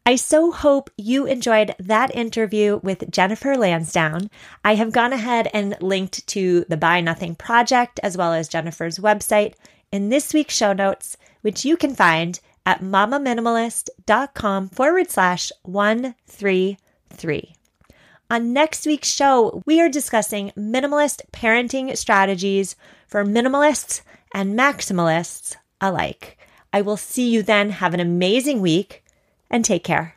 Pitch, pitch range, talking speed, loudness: 210 Hz, 190-255 Hz, 135 wpm, -19 LUFS